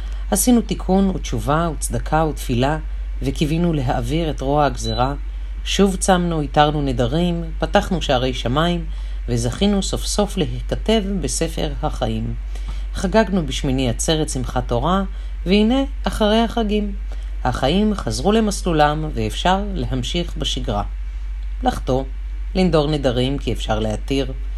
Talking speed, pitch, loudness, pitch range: 105 wpm, 150 Hz, -20 LUFS, 125-185 Hz